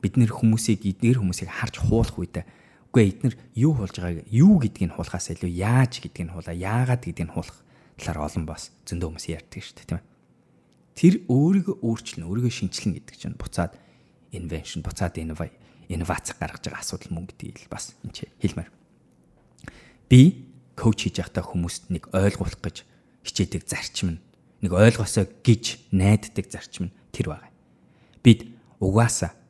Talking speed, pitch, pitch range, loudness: 155 wpm, 100 Hz, 85-120 Hz, -24 LUFS